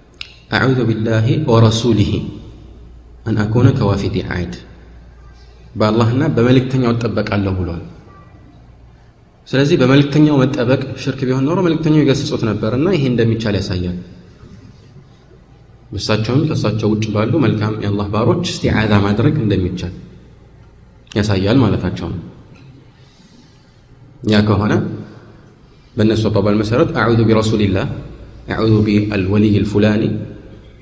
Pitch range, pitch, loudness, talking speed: 100-130 Hz, 110 Hz, -15 LUFS, 120 wpm